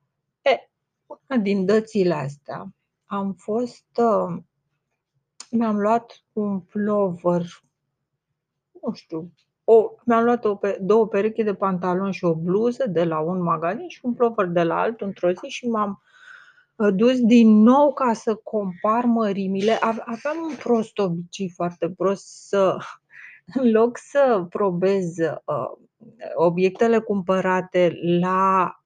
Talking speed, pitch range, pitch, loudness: 125 wpm, 175-230 Hz, 200 Hz, -21 LUFS